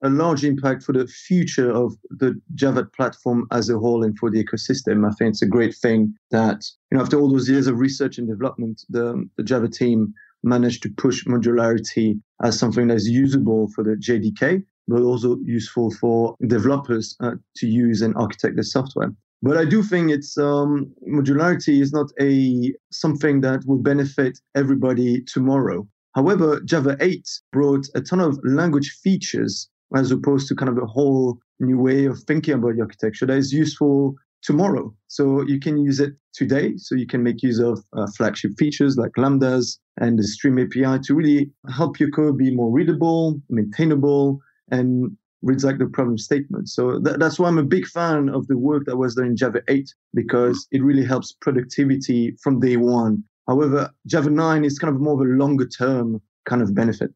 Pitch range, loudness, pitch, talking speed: 120-145 Hz, -20 LUFS, 130 Hz, 190 wpm